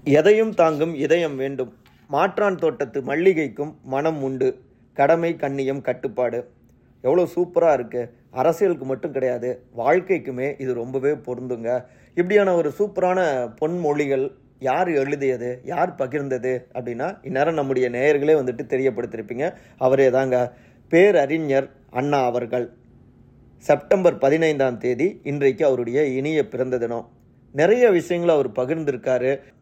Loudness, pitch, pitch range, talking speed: -21 LUFS, 135 Hz, 125-160 Hz, 105 wpm